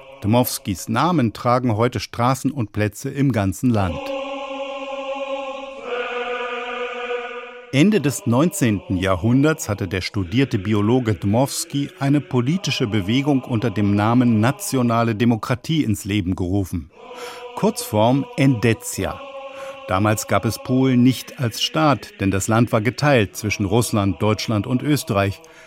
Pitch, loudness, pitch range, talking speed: 125 Hz, -20 LUFS, 110-170 Hz, 115 wpm